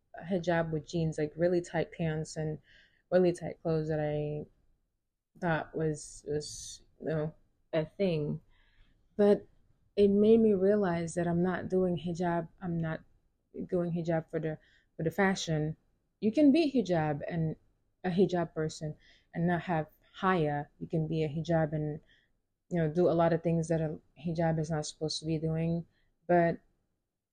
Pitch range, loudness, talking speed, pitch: 150-175 Hz, -31 LUFS, 160 wpm, 160 Hz